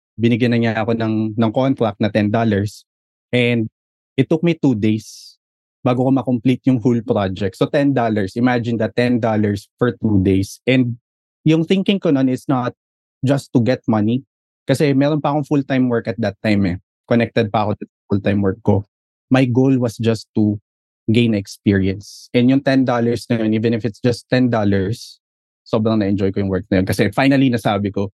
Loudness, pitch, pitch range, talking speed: -18 LUFS, 115 Hz, 105-130 Hz, 180 wpm